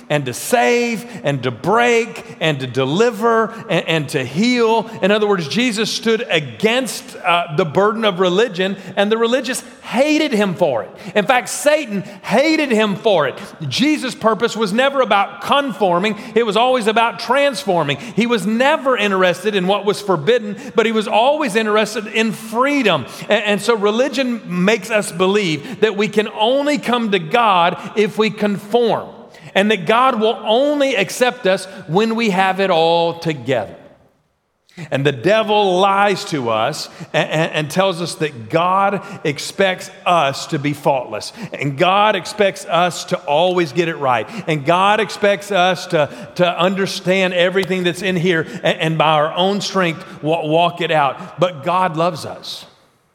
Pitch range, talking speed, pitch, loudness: 175-225 Hz, 165 wpm, 200 Hz, -17 LUFS